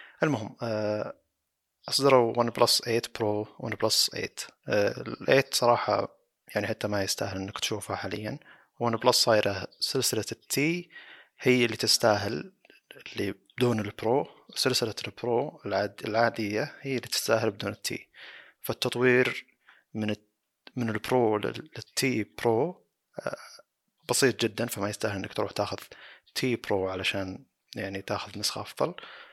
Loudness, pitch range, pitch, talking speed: -28 LUFS, 105-125 Hz, 110 Hz, 125 wpm